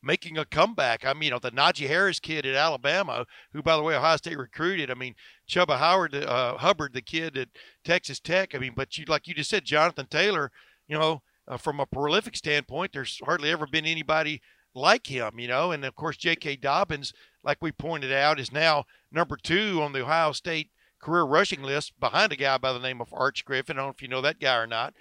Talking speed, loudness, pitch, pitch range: 230 wpm, -26 LUFS, 150 Hz, 135-165 Hz